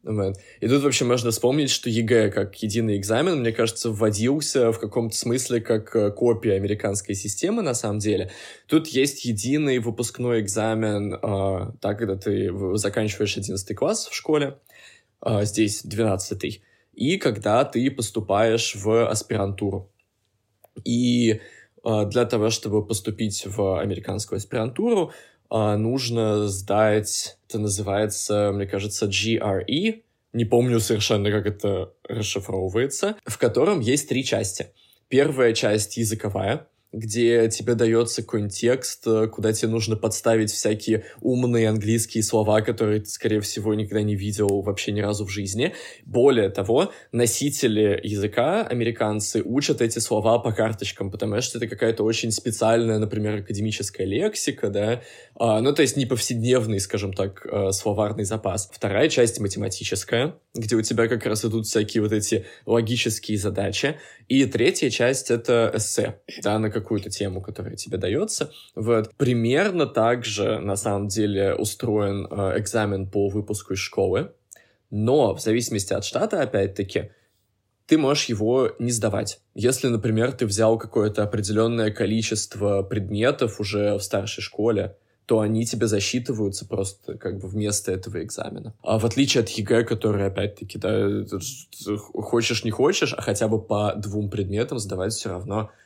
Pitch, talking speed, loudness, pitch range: 110 Hz, 140 wpm, -23 LUFS, 105-115 Hz